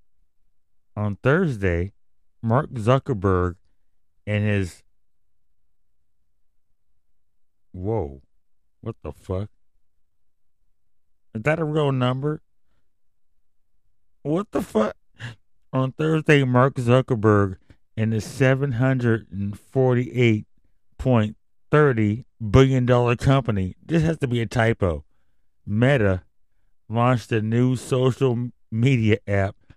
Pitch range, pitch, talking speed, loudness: 90-125 Hz, 110 Hz, 95 wpm, -22 LUFS